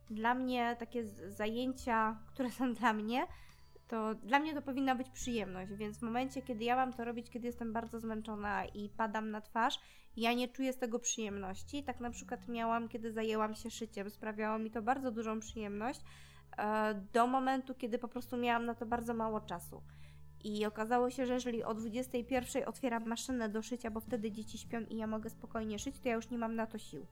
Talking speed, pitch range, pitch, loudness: 200 wpm, 220-245 Hz, 230 Hz, -38 LUFS